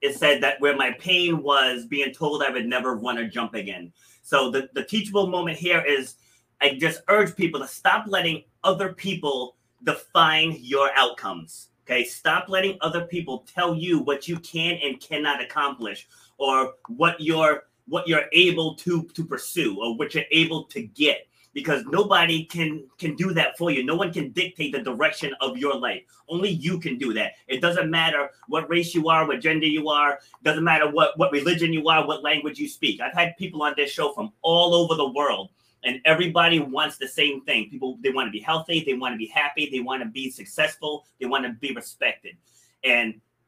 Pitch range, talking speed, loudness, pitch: 135-170 Hz, 200 wpm, -23 LUFS, 155 Hz